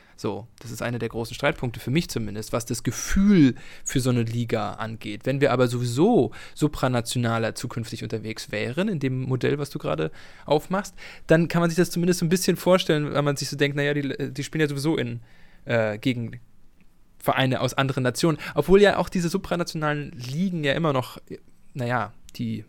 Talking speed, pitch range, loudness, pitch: 190 wpm, 120-155 Hz, -24 LUFS, 135 Hz